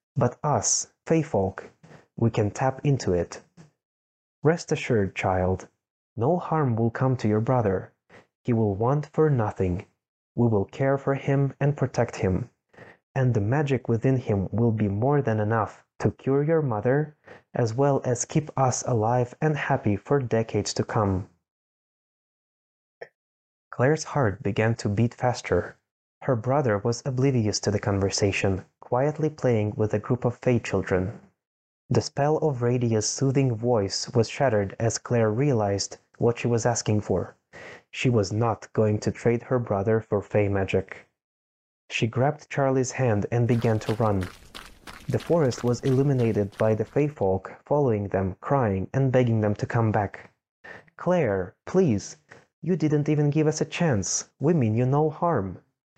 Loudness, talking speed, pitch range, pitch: -25 LUFS, 155 wpm, 105-135 Hz, 120 Hz